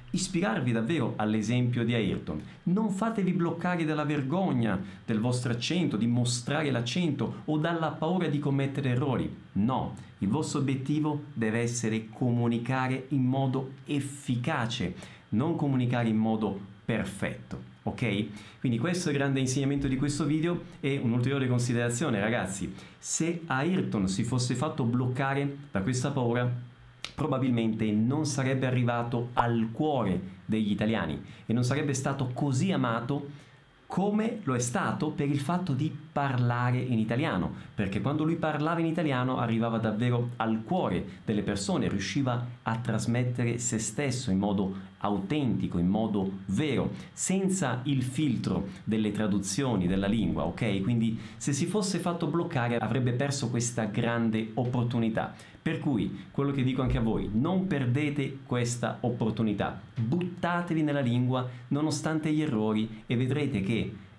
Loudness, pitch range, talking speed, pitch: -29 LUFS, 115-145 Hz, 140 wpm, 125 Hz